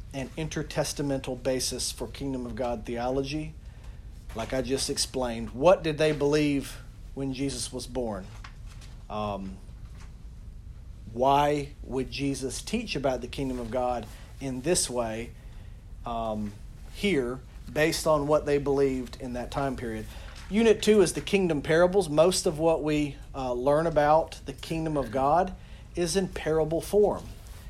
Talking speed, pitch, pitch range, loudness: 140 wpm, 130 Hz, 115-150 Hz, -28 LUFS